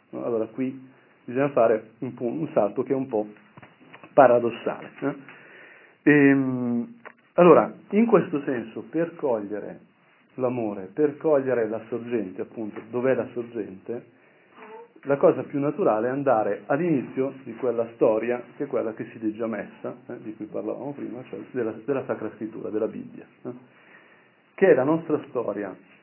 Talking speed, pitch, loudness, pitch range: 150 wpm, 125 Hz, -25 LUFS, 115-140 Hz